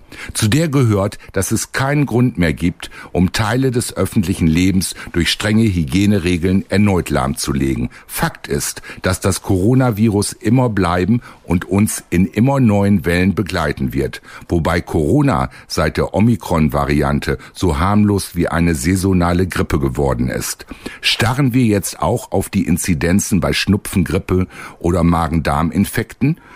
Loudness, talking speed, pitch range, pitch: -16 LUFS, 130 wpm, 85-110 Hz, 95 Hz